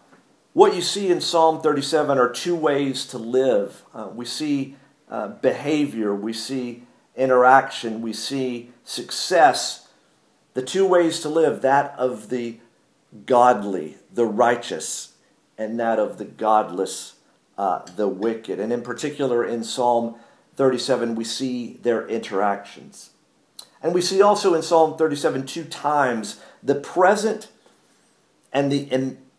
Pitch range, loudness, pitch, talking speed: 115-150 Hz, -21 LUFS, 130 Hz, 135 wpm